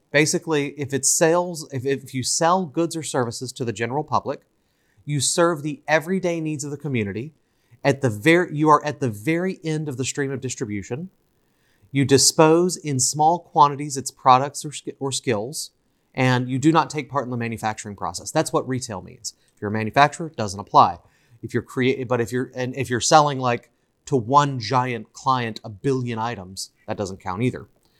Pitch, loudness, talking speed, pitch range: 135 Hz, -22 LUFS, 195 wpm, 120-150 Hz